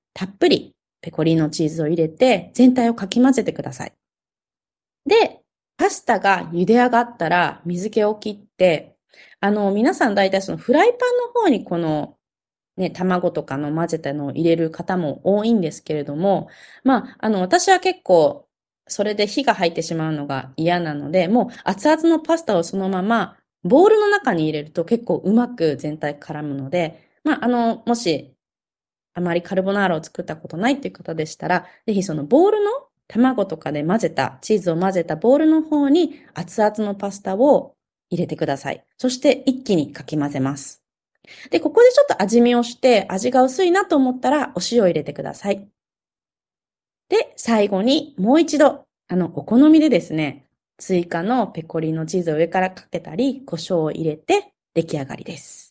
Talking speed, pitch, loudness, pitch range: 335 characters per minute, 190 Hz, -19 LUFS, 165-250 Hz